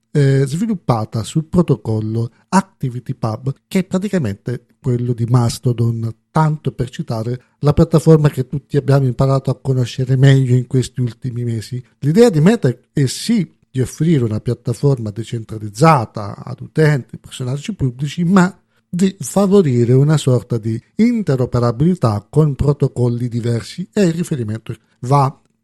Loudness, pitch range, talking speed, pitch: -17 LUFS, 120-155 Hz, 130 wpm, 130 Hz